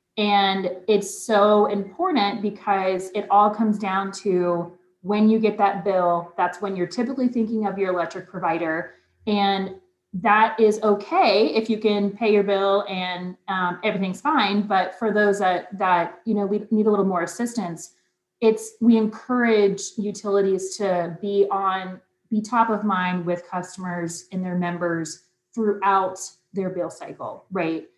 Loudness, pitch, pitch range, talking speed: -22 LUFS, 195 Hz, 180-210 Hz, 155 wpm